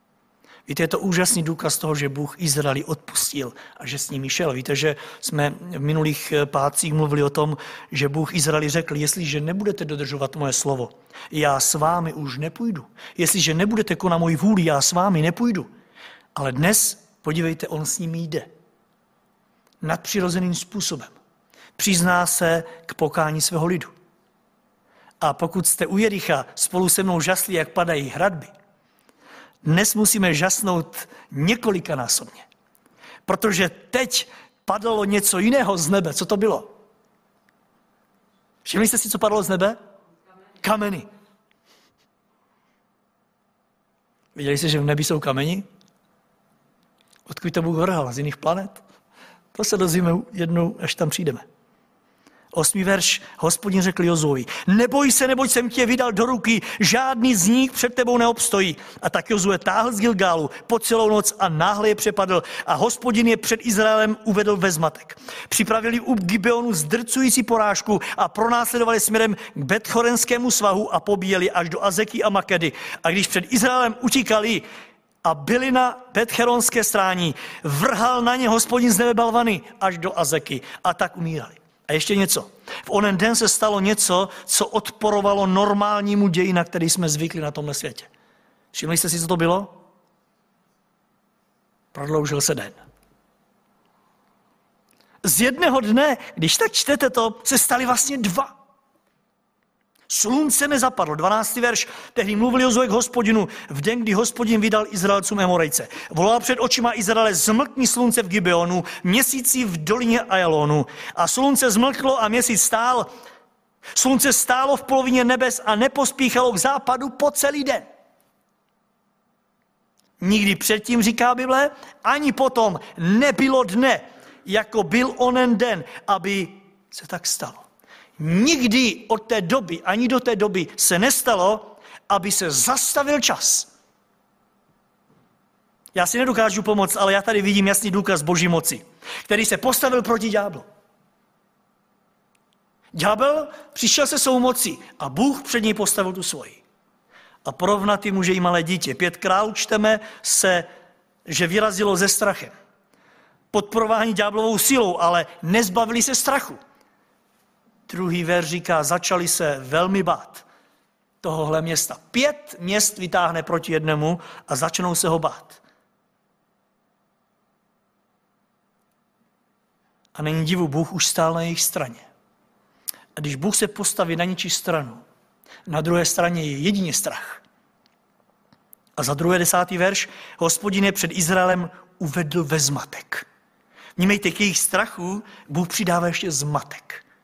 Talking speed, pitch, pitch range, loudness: 135 wpm, 205 Hz, 175-230 Hz, -20 LUFS